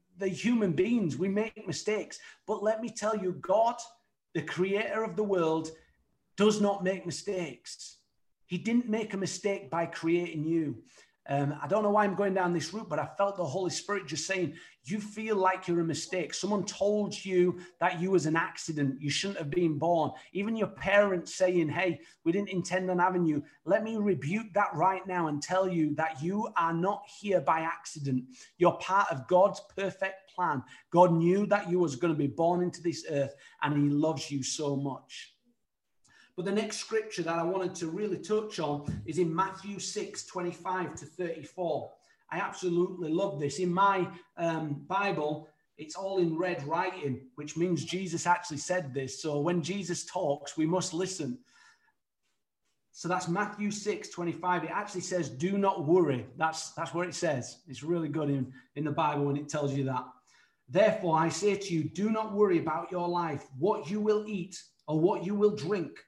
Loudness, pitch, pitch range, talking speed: -31 LUFS, 180 Hz, 160-200 Hz, 190 wpm